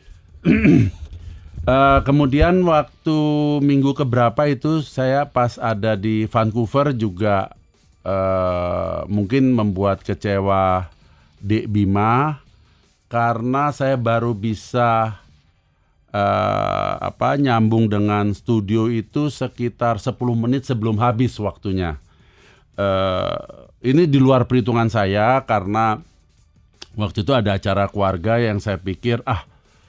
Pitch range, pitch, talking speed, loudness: 100-130 Hz, 110 Hz, 100 wpm, -19 LUFS